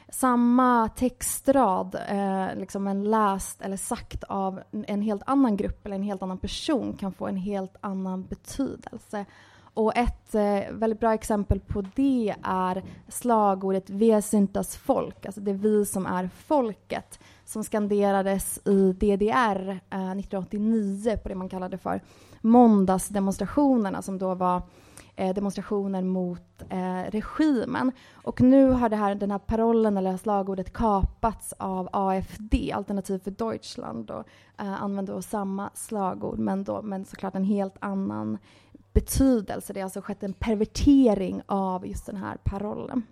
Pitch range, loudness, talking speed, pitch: 190-220 Hz, -26 LUFS, 140 wpm, 200 Hz